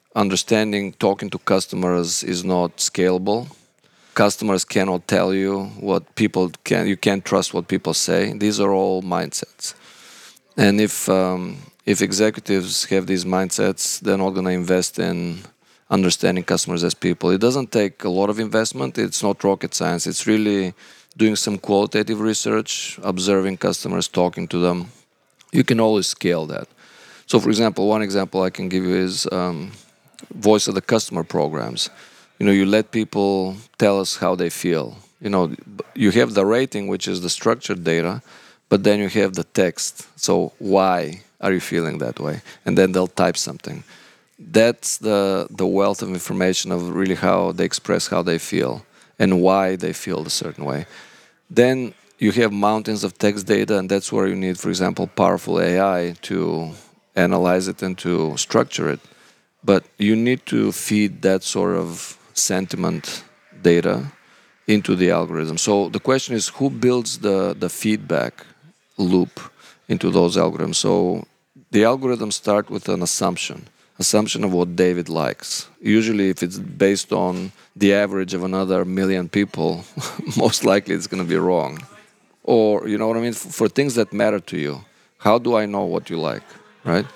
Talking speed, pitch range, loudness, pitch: 170 wpm, 90-105 Hz, -20 LUFS, 100 Hz